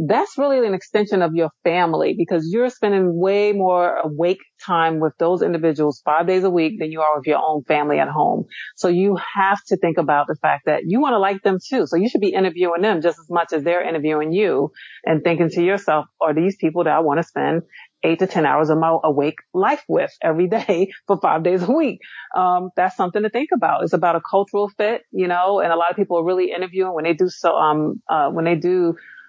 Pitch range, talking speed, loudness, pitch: 165-195 Hz, 240 wpm, -19 LUFS, 175 Hz